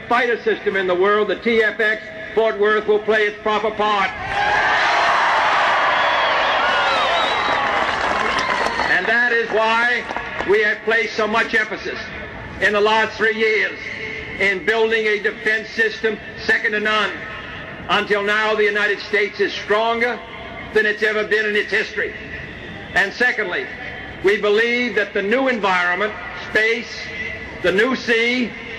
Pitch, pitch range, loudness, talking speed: 215 Hz, 210-230 Hz, -18 LUFS, 130 wpm